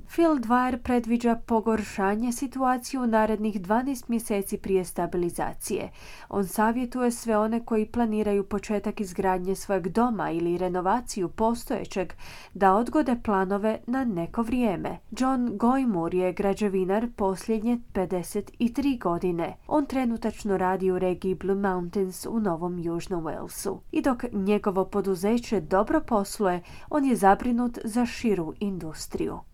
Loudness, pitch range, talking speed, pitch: -27 LUFS, 190-240 Hz, 120 wpm, 210 Hz